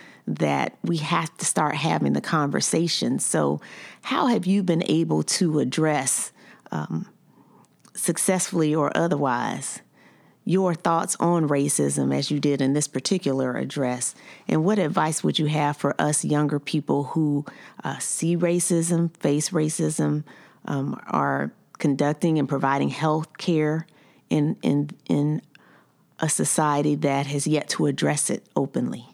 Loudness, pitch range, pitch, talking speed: -24 LUFS, 145-170 Hz, 150 Hz, 135 wpm